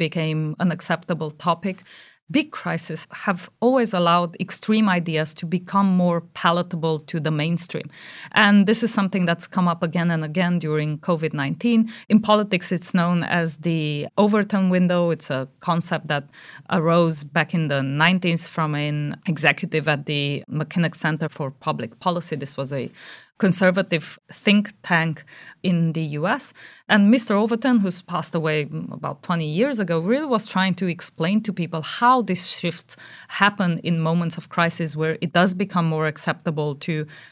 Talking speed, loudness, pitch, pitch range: 160 wpm, -21 LUFS, 170 Hz, 155-185 Hz